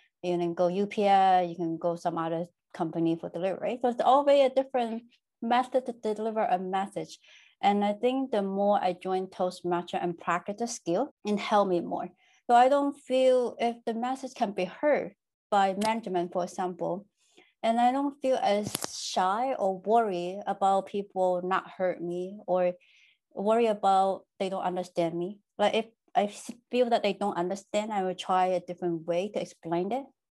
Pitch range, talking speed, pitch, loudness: 180-235 Hz, 175 wpm, 200 Hz, -28 LUFS